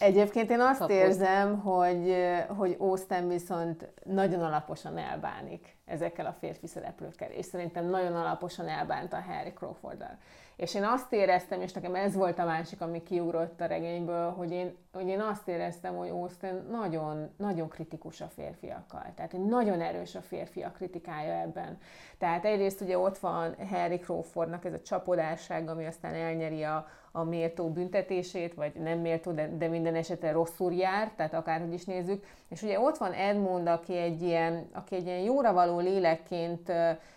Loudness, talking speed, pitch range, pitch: -32 LUFS, 165 wpm, 165-190 Hz, 175 Hz